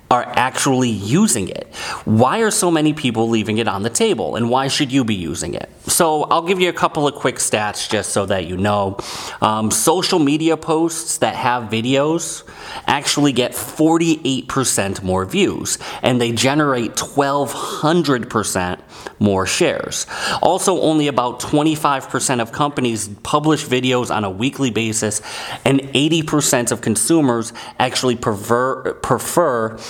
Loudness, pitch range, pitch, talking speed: -17 LUFS, 110-150 Hz, 125 Hz, 145 wpm